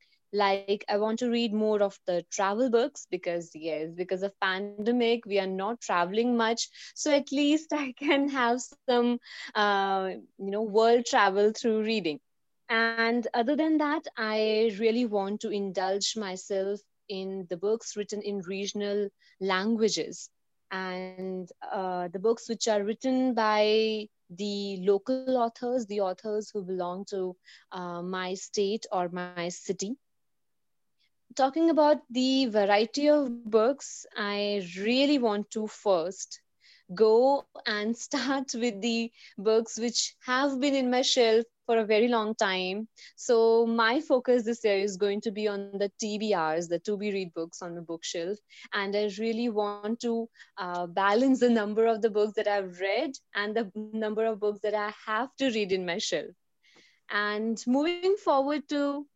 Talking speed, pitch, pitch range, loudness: 155 wpm, 215 Hz, 200-240 Hz, -28 LUFS